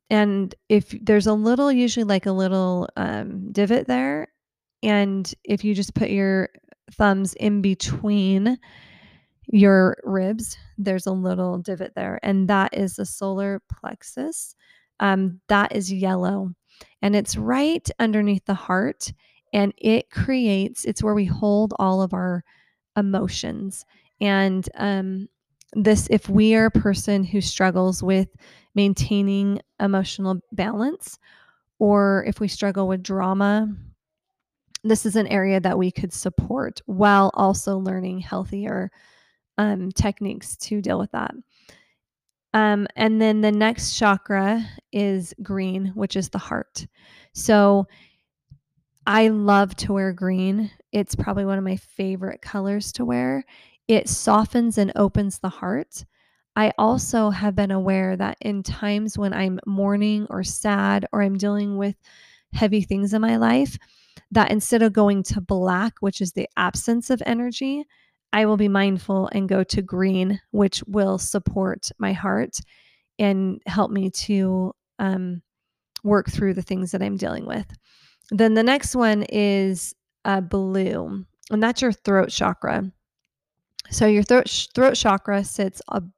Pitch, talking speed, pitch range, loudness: 200 Hz, 145 wpm, 190-215 Hz, -22 LUFS